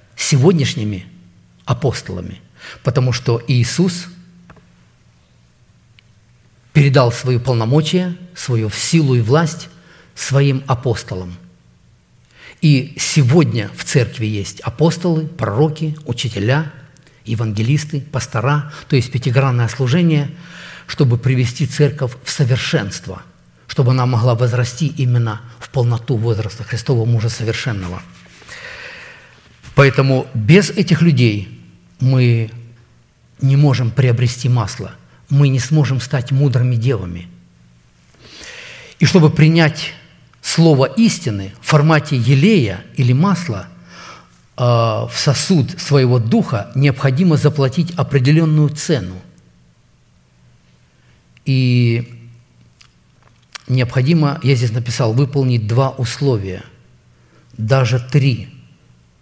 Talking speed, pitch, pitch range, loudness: 90 wpm, 130 Hz, 115-145 Hz, -16 LUFS